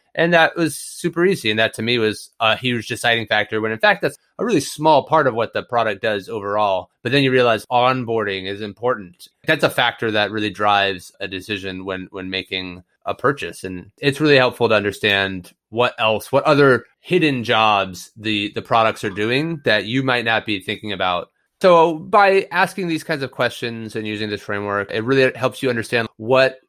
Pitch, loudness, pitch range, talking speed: 115 Hz, -19 LUFS, 105-130 Hz, 200 wpm